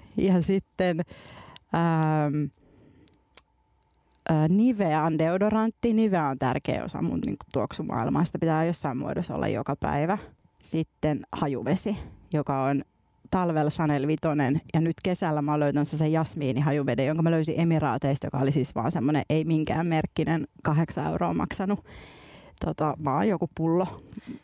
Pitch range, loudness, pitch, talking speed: 145-175 Hz, -27 LUFS, 160 Hz, 140 wpm